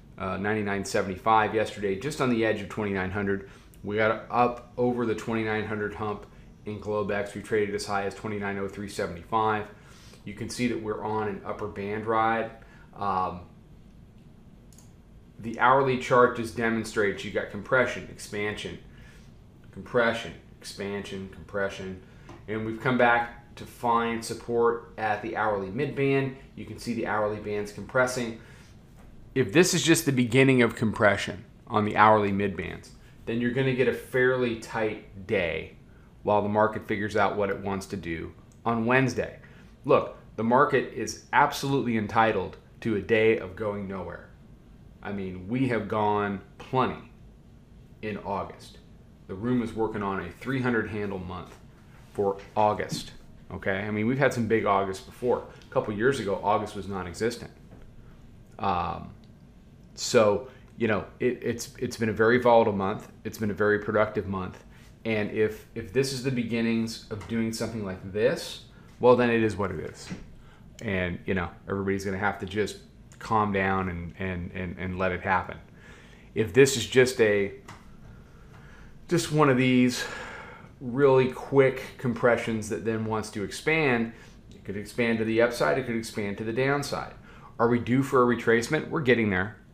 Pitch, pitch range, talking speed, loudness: 110 Hz, 100-120 Hz, 160 wpm, -27 LUFS